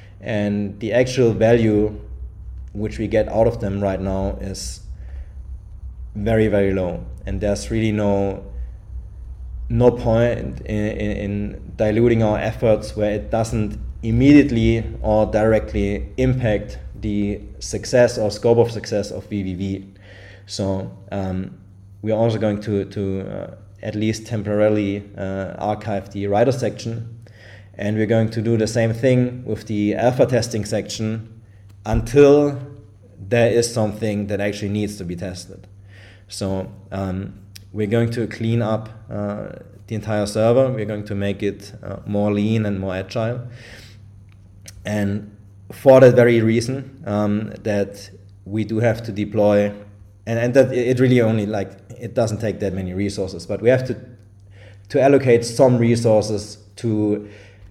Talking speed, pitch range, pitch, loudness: 140 wpm, 100-115 Hz, 105 Hz, -20 LUFS